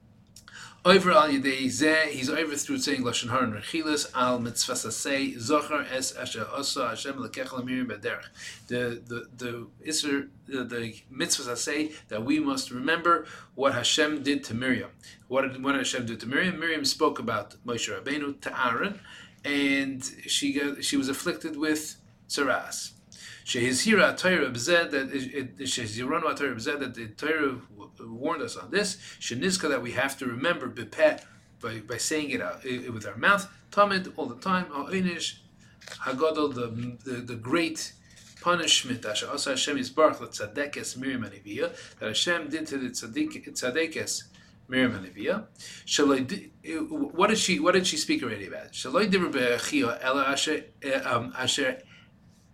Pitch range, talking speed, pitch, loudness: 125-165 Hz, 165 wpm, 140 Hz, -27 LUFS